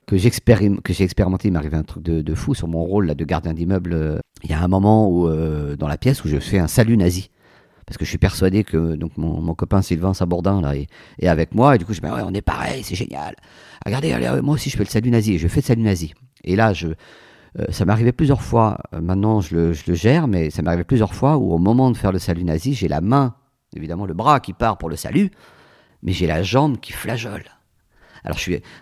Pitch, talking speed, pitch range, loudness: 95 Hz, 260 wpm, 85-115 Hz, -19 LUFS